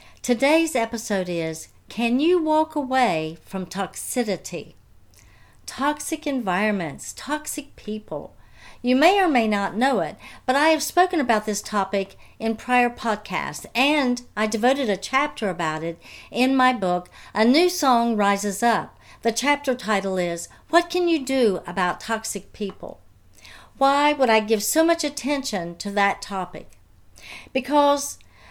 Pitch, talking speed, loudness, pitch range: 230 Hz, 140 wpm, -22 LUFS, 195-280 Hz